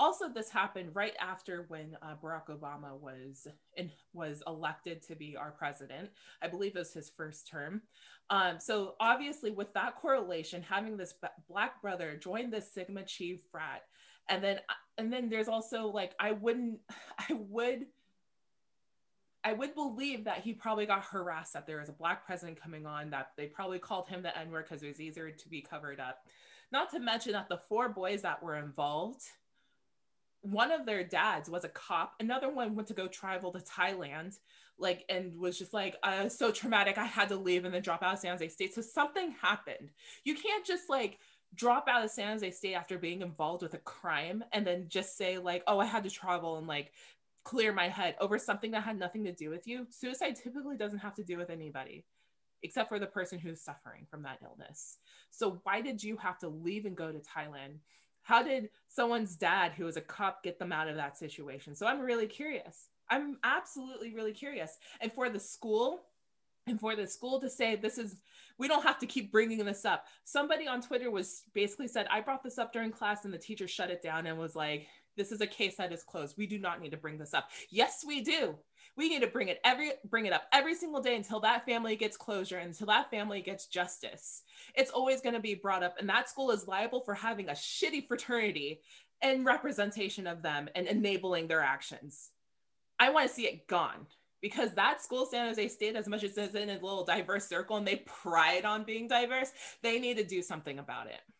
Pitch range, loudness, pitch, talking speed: 170-230 Hz, -35 LUFS, 200 Hz, 215 wpm